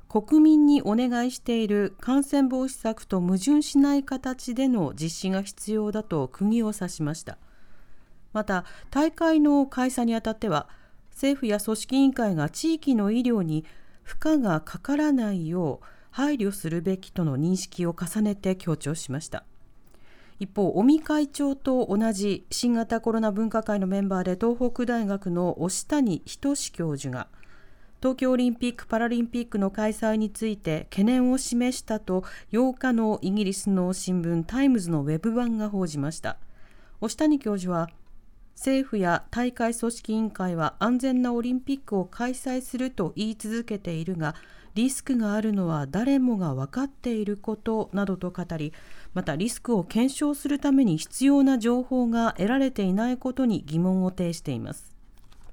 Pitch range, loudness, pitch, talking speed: 180-255 Hz, -26 LUFS, 220 Hz, 310 characters per minute